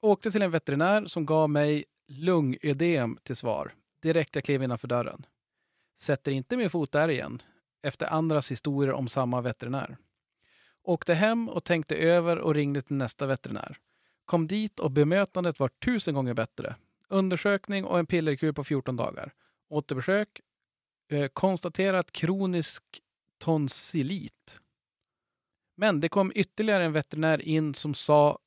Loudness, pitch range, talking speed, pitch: -28 LUFS, 140-180 Hz, 135 wpm, 155 Hz